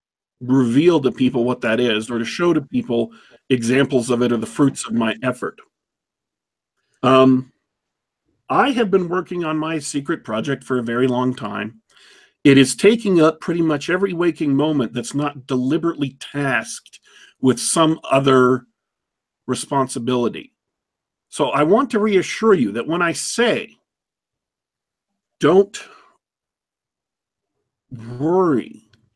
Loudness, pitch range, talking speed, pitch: -18 LUFS, 125-165 Hz, 130 wpm, 135 Hz